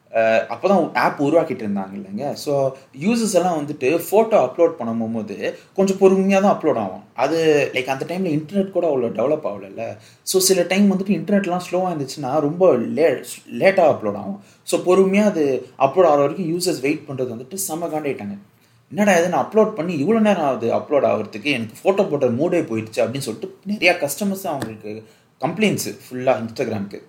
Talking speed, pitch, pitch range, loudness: 155 wpm, 155 Hz, 125-190 Hz, -19 LUFS